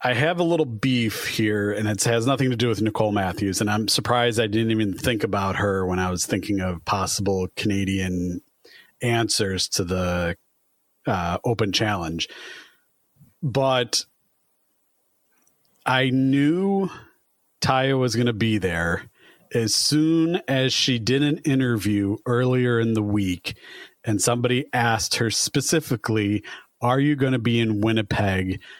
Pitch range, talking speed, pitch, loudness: 100-130 Hz, 145 wpm, 115 Hz, -22 LUFS